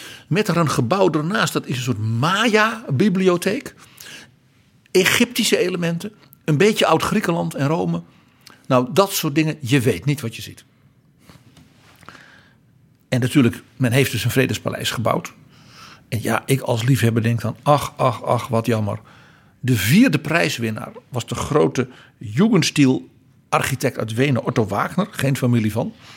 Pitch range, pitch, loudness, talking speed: 120-170 Hz, 135 Hz, -19 LUFS, 140 wpm